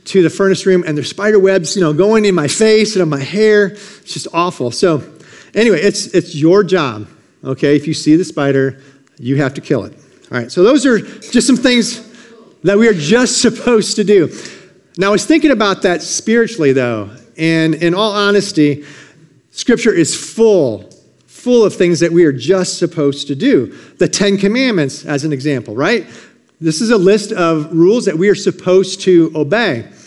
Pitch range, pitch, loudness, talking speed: 150-210 Hz, 185 Hz, -13 LUFS, 195 wpm